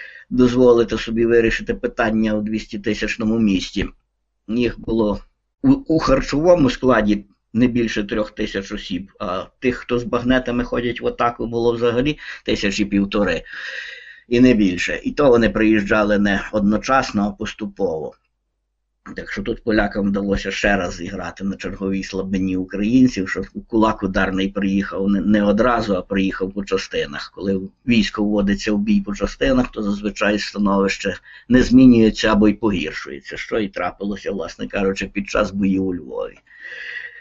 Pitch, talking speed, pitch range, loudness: 105 Hz, 145 wpm, 100-120 Hz, -19 LUFS